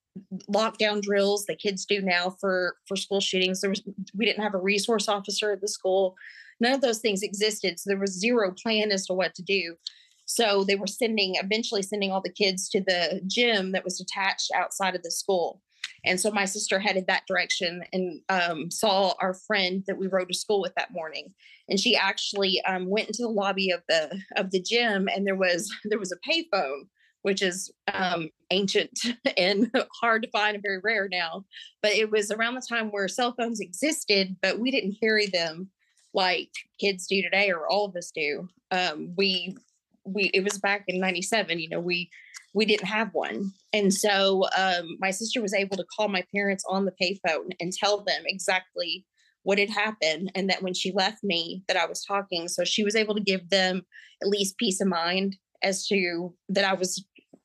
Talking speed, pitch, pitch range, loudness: 205 wpm, 195 Hz, 185-210 Hz, -26 LUFS